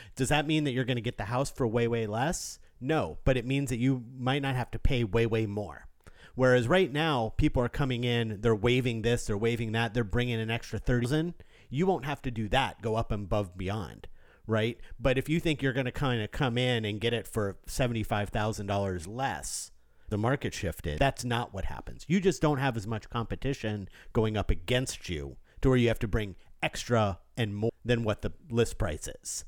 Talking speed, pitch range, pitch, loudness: 230 wpm, 110-130 Hz, 120 Hz, -30 LUFS